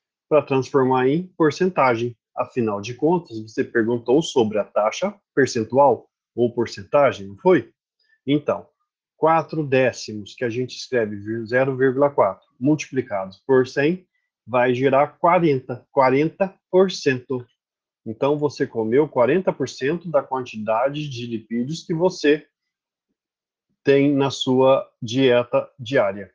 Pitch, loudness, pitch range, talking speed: 135 Hz, -21 LUFS, 120-155 Hz, 105 wpm